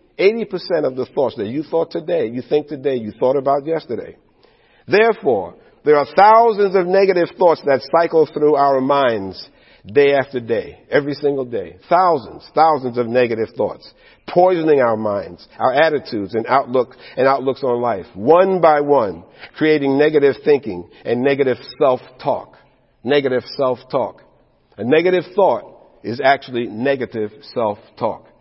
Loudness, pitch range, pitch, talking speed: -17 LUFS, 125-165 Hz, 140 Hz, 140 wpm